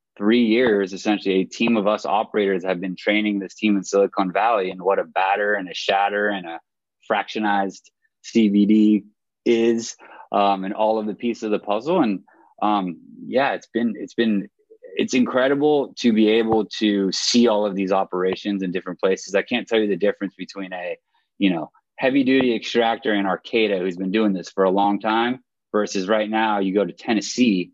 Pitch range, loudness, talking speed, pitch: 100-115 Hz, -21 LUFS, 190 wpm, 105 Hz